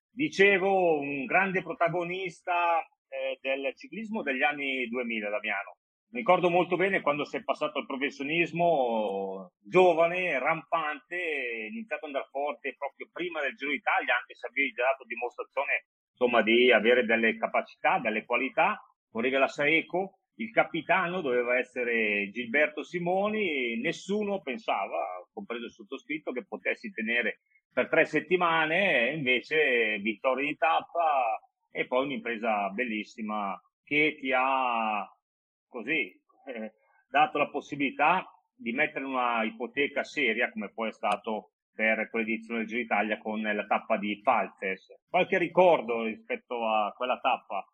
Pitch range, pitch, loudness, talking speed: 120-180 Hz, 145 Hz, -28 LUFS, 135 wpm